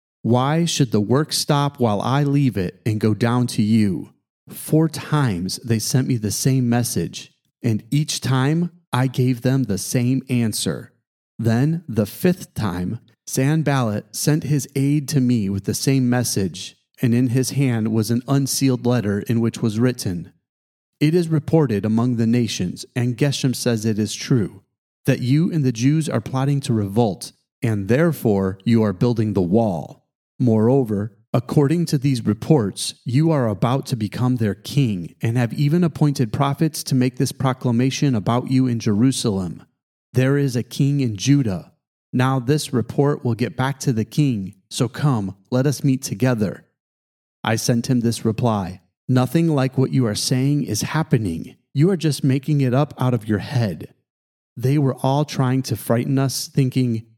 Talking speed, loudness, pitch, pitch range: 170 wpm, -20 LUFS, 125 Hz, 115-140 Hz